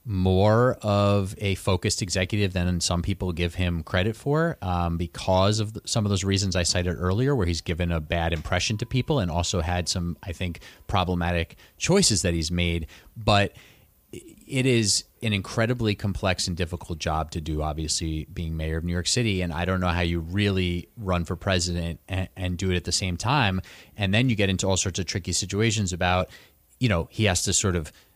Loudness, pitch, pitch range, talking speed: -25 LUFS, 95 Hz, 85-105 Hz, 205 wpm